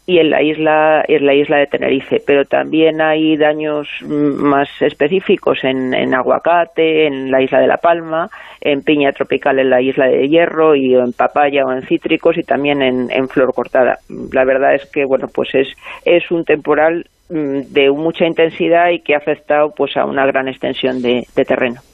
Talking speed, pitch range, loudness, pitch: 190 wpm, 135-160 Hz, -14 LUFS, 145 Hz